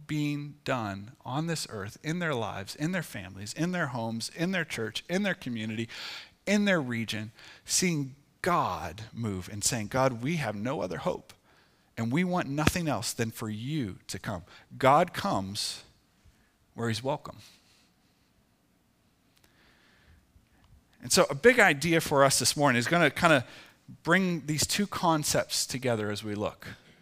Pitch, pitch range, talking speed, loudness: 135 Hz, 110-160 Hz, 160 wpm, -28 LUFS